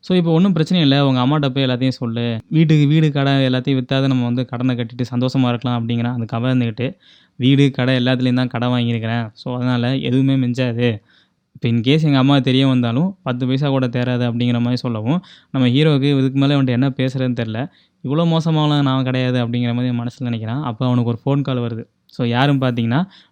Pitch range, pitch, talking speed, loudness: 120-140 Hz, 130 Hz, 185 wpm, -18 LUFS